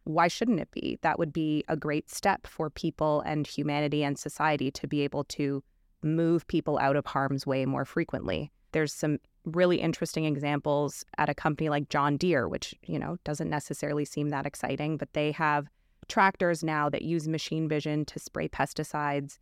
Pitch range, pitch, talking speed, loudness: 145-160 Hz, 150 Hz, 180 wpm, -30 LUFS